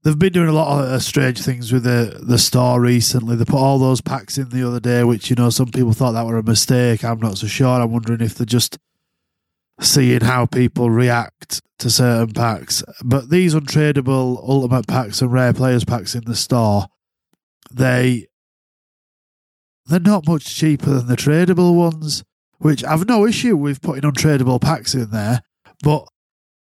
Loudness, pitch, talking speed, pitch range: -17 LUFS, 125 Hz, 180 wpm, 120-145 Hz